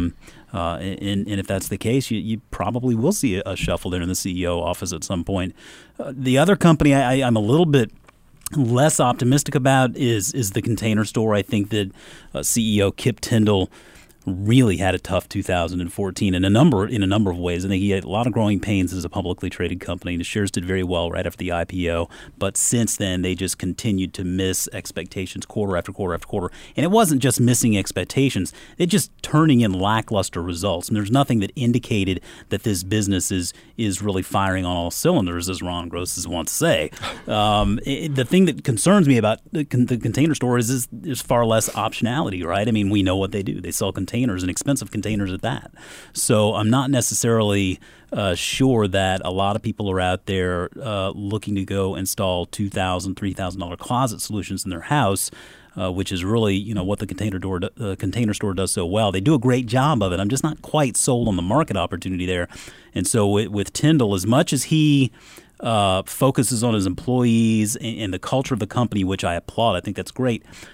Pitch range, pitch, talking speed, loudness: 95-120 Hz, 100 Hz, 210 wpm, -21 LUFS